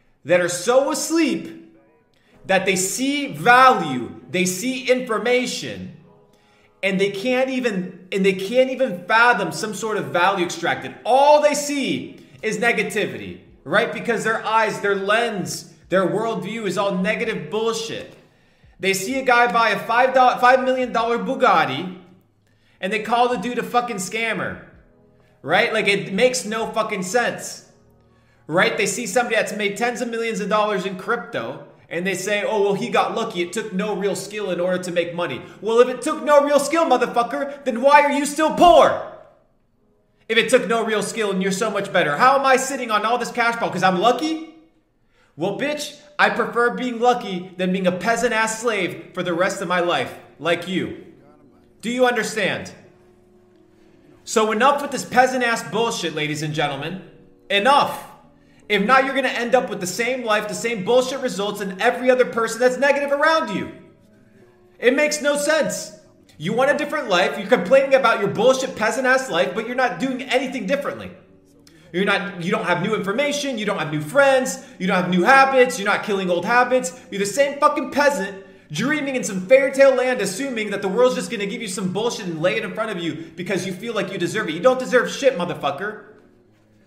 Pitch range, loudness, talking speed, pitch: 195-255 Hz, -20 LUFS, 190 wpm, 225 Hz